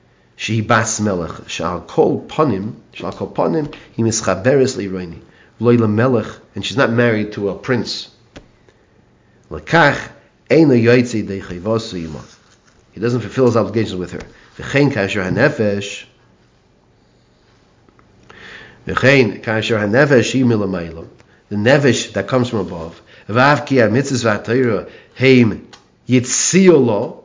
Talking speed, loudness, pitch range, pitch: 130 wpm, -16 LUFS, 100-125 Hz, 110 Hz